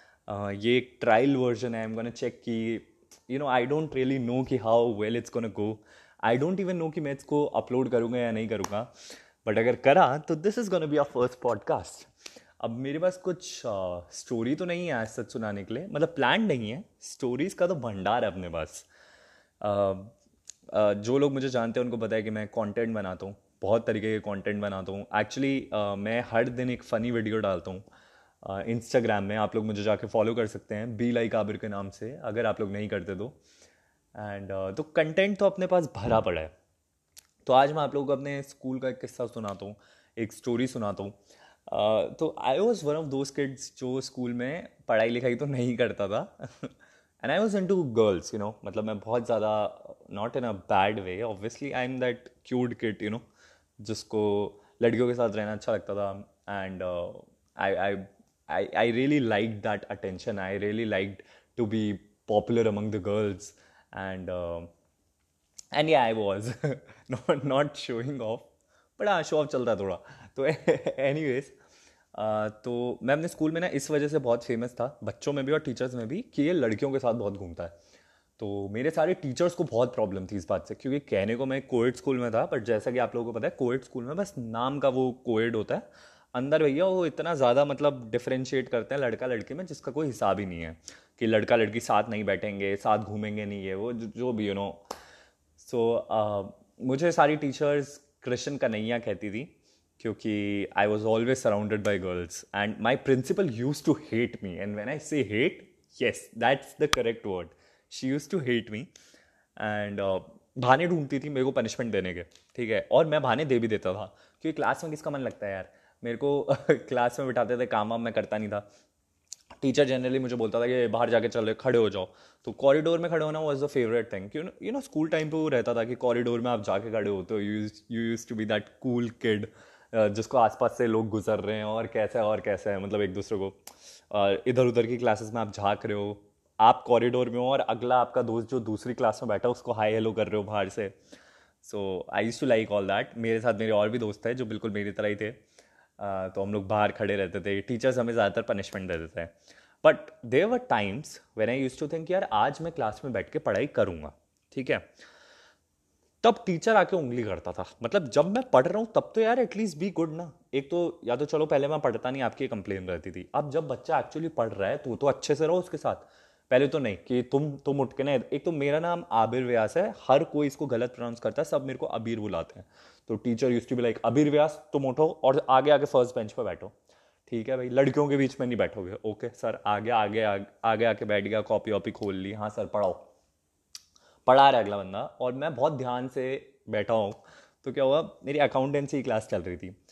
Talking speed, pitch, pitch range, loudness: 220 wpm, 115 Hz, 105-135 Hz, -28 LUFS